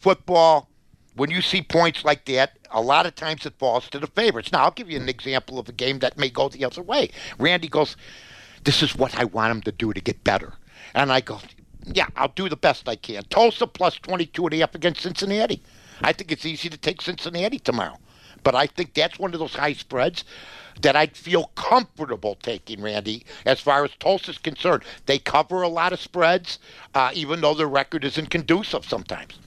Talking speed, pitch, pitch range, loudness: 215 wpm, 155 Hz, 135-175 Hz, -22 LUFS